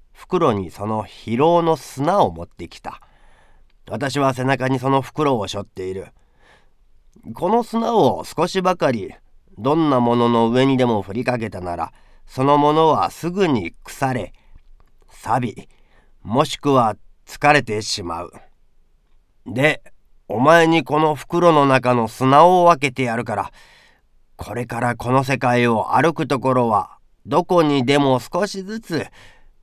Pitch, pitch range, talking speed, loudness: 130 Hz, 110-155 Hz, 245 characters per minute, -18 LUFS